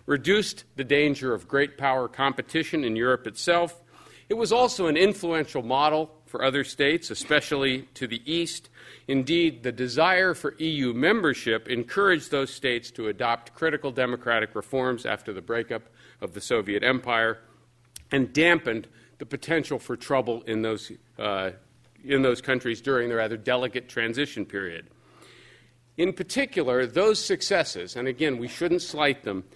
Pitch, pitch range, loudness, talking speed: 130 Hz, 120-155 Hz, -25 LUFS, 145 wpm